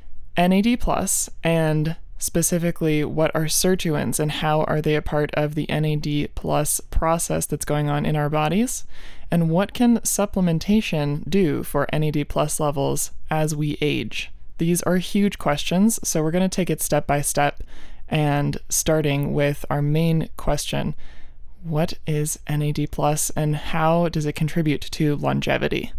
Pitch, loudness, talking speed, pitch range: 155 Hz, -22 LUFS, 150 wpm, 145-170 Hz